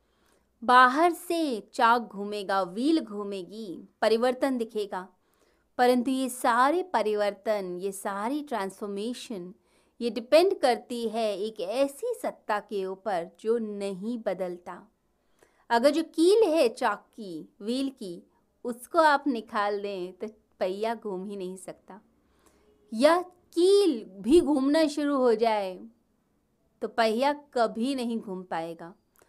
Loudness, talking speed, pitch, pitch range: -27 LUFS, 120 wpm, 230 Hz, 200-270 Hz